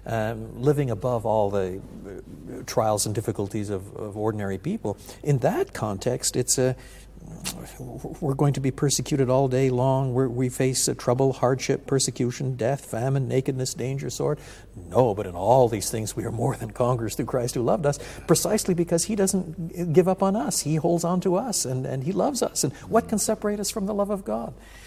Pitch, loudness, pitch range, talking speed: 130 Hz, -25 LUFS, 115-150 Hz, 200 wpm